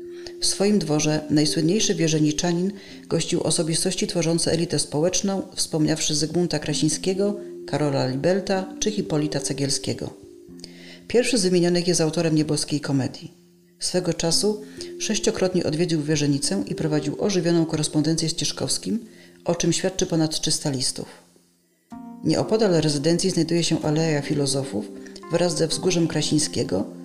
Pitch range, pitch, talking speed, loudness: 150-180 Hz, 160 Hz, 115 wpm, -23 LUFS